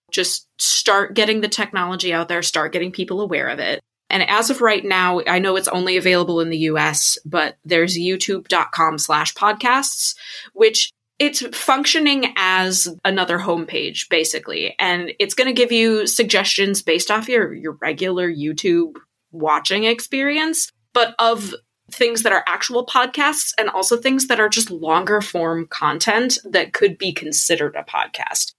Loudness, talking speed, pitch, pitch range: -18 LUFS, 155 wpm, 195 Hz, 175-245 Hz